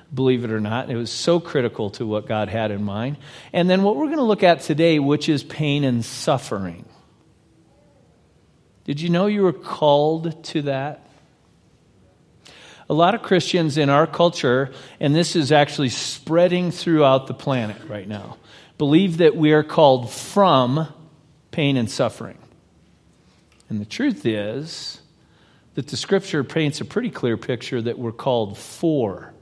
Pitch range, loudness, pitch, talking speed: 120-165 Hz, -20 LUFS, 145 Hz, 160 wpm